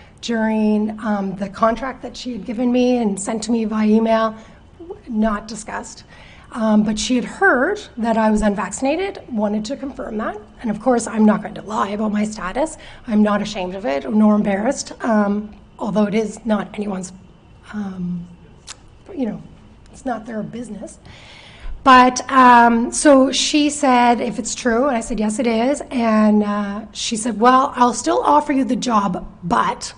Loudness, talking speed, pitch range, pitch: -18 LUFS, 175 wpm, 210-250 Hz, 225 Hz